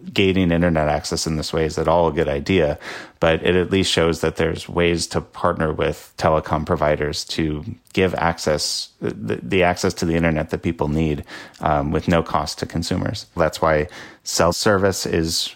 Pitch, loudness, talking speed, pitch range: 85 Hz, -20 LUFS, 185 wpm, 80-90 Hz